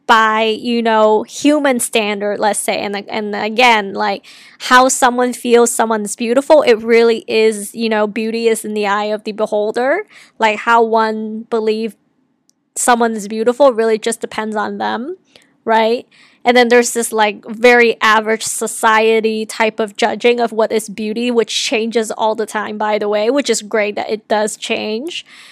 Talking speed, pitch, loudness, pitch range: 165 wpm, 225 Hz, -14 LUFS, 215-240 Hz